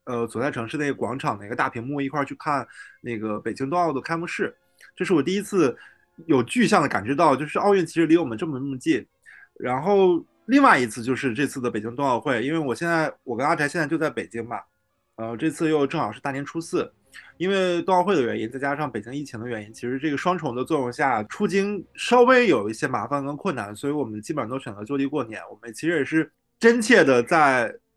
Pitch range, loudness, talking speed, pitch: 120-170 Hz, -23 LUFS, 350 characters per minute, 145 Hz